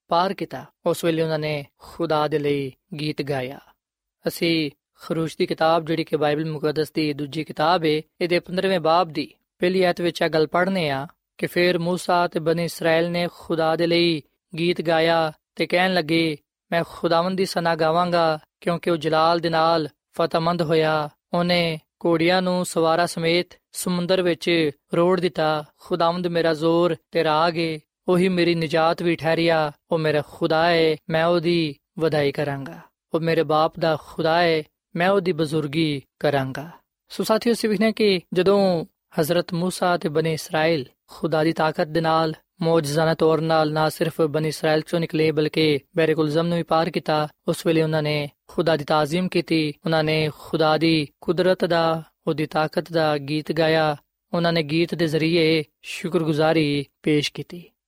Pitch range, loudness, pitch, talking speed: 155-175 Hz, -22 LUFS, 165 Hz, 160 wpm